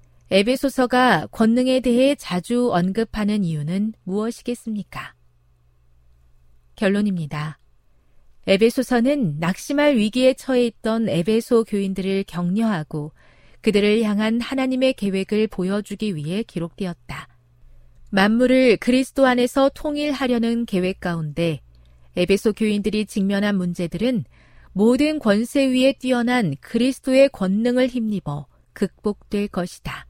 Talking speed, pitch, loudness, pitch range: 280 characters per minute, 210 Hz, -20 LUFS, 175-245 Hz